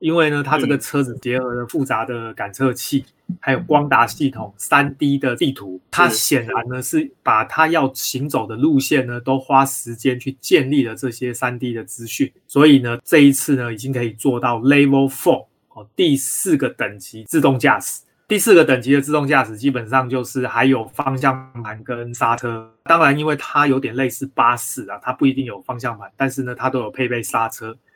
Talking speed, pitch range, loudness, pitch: 305 characters per minute, 120-140 Hz, -18 LUFS, 130 Hz